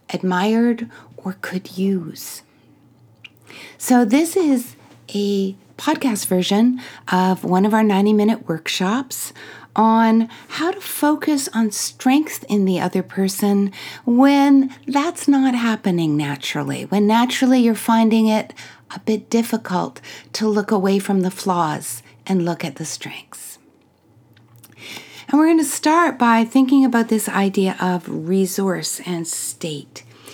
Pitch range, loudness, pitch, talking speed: 185-245 Hz, -18 LUFS, 210 Hz, 130 wpm